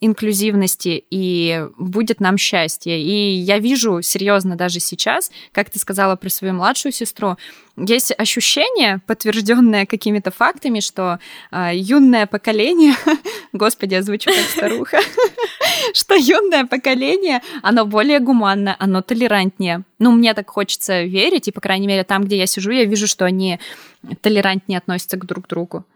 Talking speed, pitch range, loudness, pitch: 145 wpm, 190-240 Hz, -16 LUFS, 205 Hz